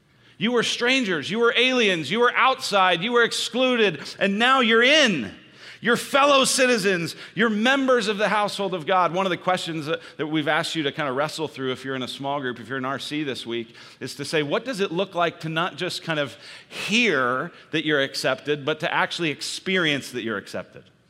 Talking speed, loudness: 215 wpm, -22 LUFS